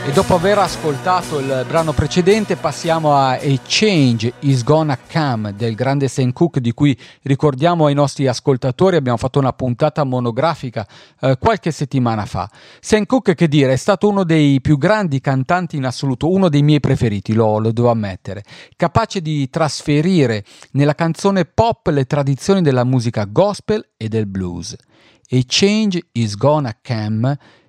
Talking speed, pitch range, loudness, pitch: 160 wpm, 125-165 Hz, -16 LUFS, 140 Hz